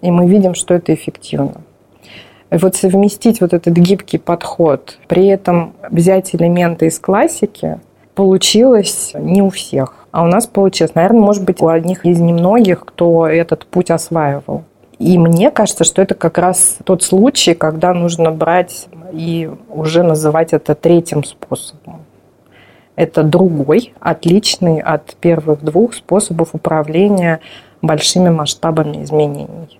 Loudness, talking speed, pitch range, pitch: -12 LUFS, 135 wpm, 160-190 Hz, 170 Hz